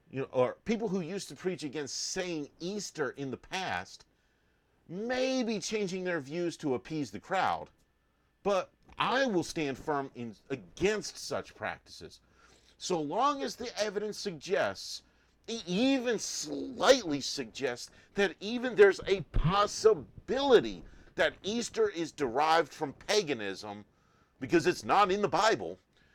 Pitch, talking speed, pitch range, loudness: 180 Hz, 135 wpm, 145-210 Hz, -31 LUFS